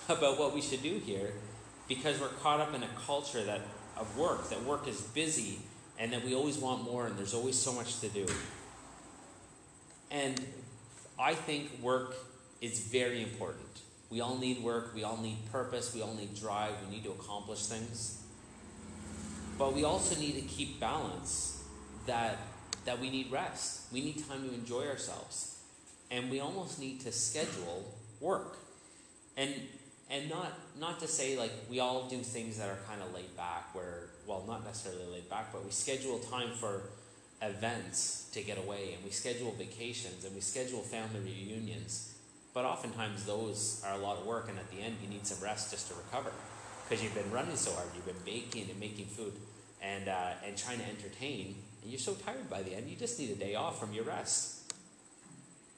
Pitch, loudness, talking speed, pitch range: 115 Hz, -38 LUFS, 190 wpm, 105-130 Hz